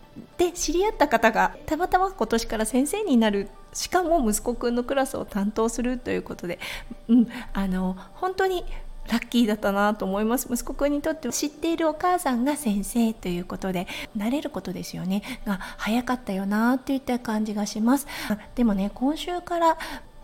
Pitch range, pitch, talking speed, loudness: 215-300 Hz, 245 Hz, 375 characters per minute, -25 LUFS